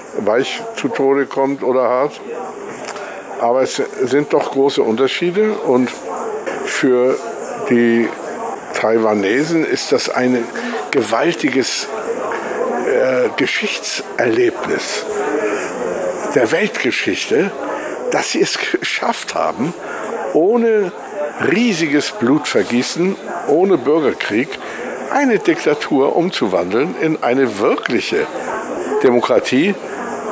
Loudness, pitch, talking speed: -17 LUFS, 145 Hz, 80 wpm